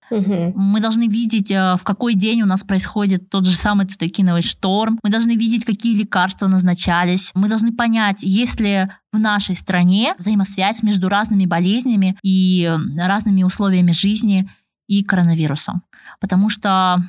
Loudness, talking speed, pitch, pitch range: -17 LUFS, 140 wpm, 195 Hz, 185-210 Hz